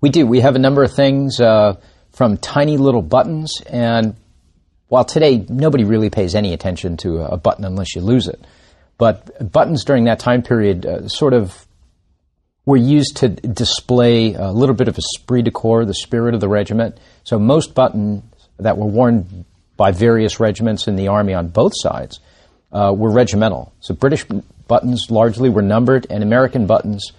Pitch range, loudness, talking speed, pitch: 100-125 Hz, -15 LUFS, 180 wpm, 110 Hz